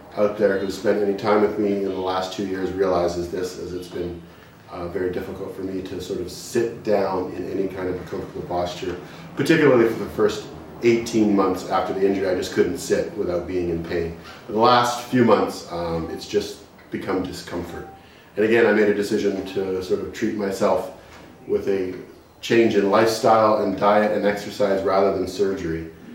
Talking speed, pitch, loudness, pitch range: 195 wpm, 95 Hz, -22 LUFS, 90-105 Hz